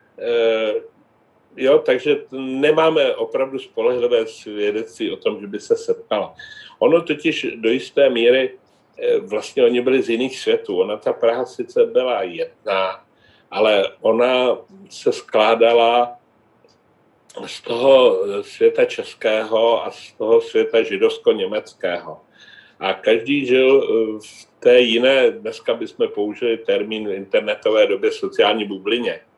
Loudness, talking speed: -18 LUFS, 120 wpm